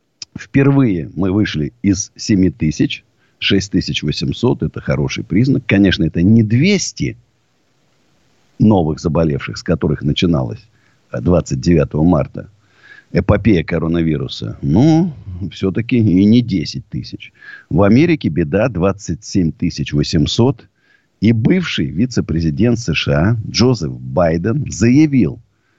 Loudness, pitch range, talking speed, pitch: -15 LUFS, 80-120 Hz, 95 wpm, 100 Hz